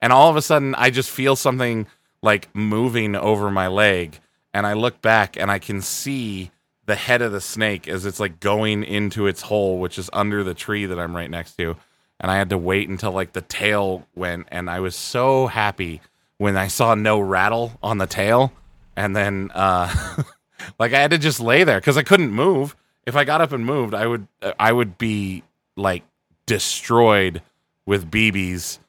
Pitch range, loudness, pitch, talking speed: 95-115 Hz, -20 LUFS, 105 Hz, 200 wpm